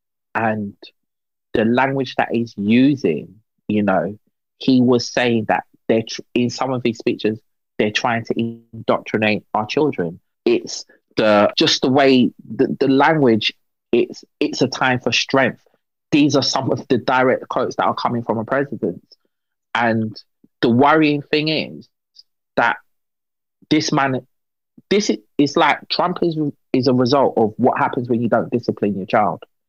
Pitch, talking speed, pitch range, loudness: 125 Hz, 160 wpm, 115-135 Hz, -18 LUFS